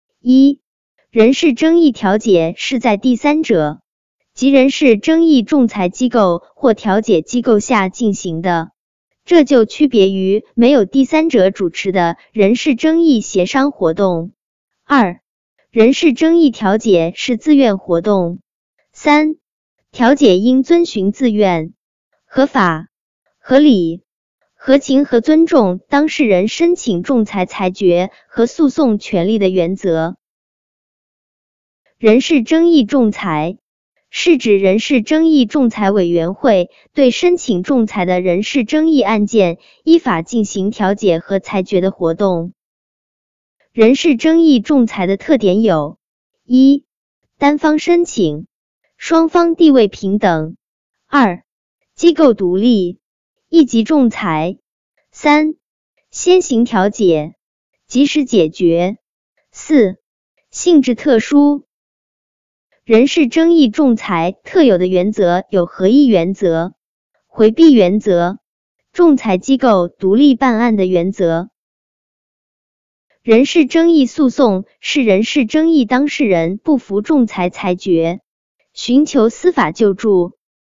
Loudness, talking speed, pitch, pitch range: -13 LUFS, 180 characters per minute, 230 Hz, 190-285 Hz